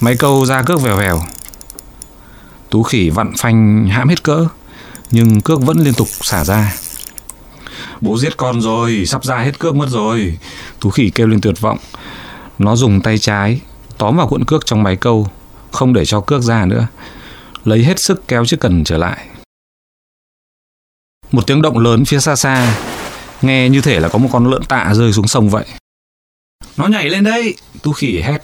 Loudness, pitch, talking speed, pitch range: -13 LUFS, 115 Hz, 185 wpm, 105-135 Hz